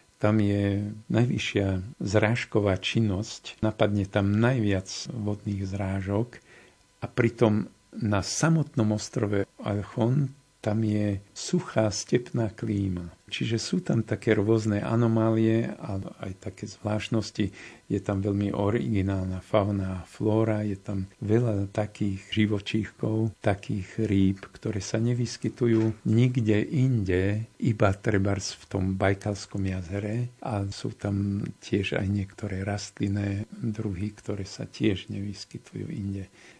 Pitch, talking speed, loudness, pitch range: 105 Hz, 110 wpm, -28 LUFS, 100-110 Hz